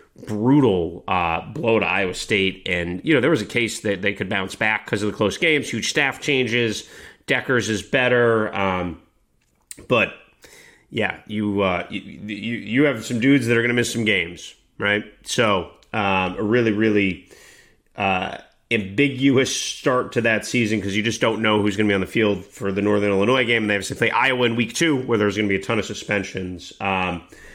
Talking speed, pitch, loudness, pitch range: 205 wpm, 105 Hz, -21 LUFS, 100-120 Hz